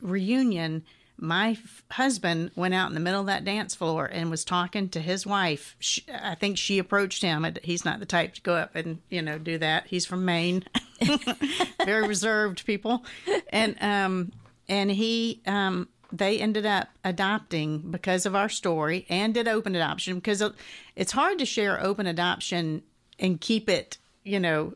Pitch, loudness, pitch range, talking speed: 195 Hz, -27 LUFS, 170-215 Hz, 175 wpm